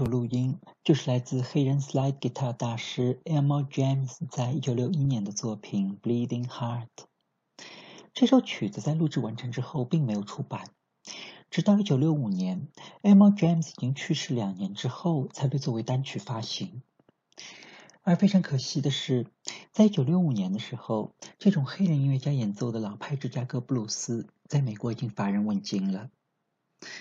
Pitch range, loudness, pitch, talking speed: 125-165 Hz, -28 LUFS, 135 Hz, 325 characters per minute